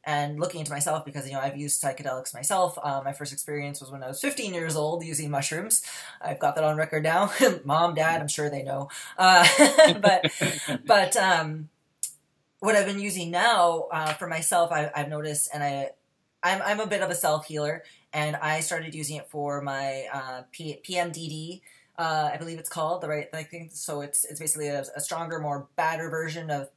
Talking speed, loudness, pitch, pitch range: 200 wpm, -25 LUFS, 155 Hz, 145-170 Hz